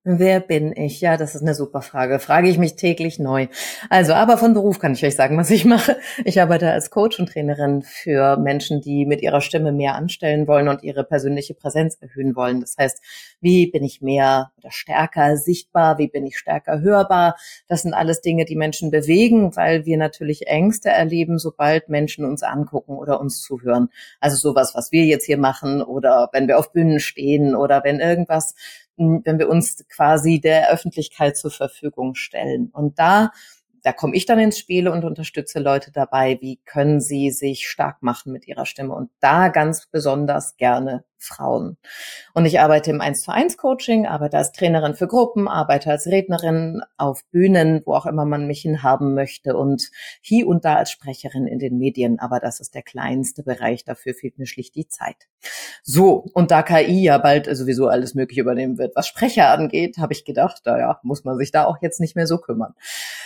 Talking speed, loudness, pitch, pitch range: 190 wpm, -18 LUFS, 150 Hz, 140-170 Hz